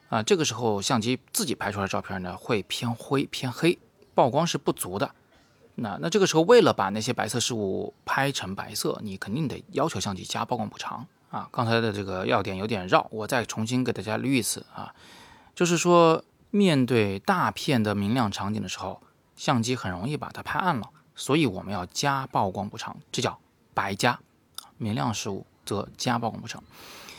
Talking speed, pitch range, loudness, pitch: 285 characters per minute, 100-135 Hz, -26 LUFS, 115 Hz